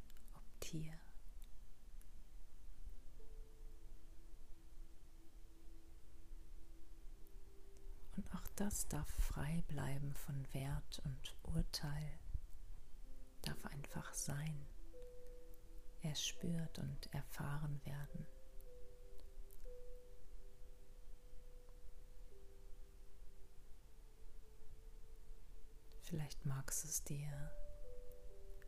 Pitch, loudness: 145 Hz, -48 LUFS